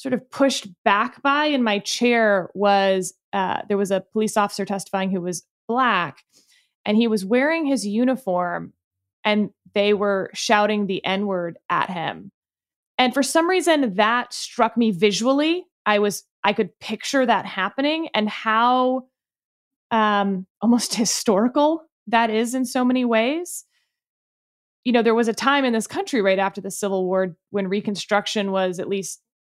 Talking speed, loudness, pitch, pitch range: 160 wpm, -21 LUFS, 220 Hz, 195-255 Hz